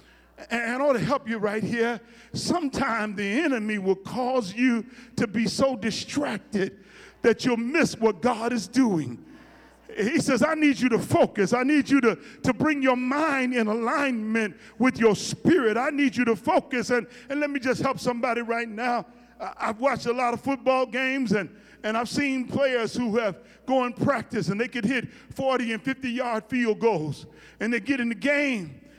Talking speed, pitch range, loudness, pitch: 190 wpm, 220-265 Hz, -25 LUFS, 240 Hz